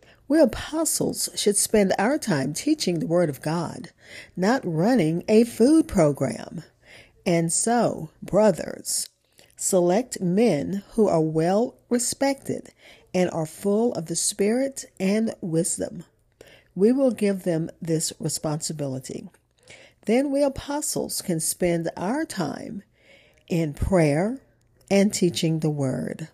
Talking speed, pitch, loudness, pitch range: 120 wpm, 190 Hz, -23 LUFS, 165-230 Hz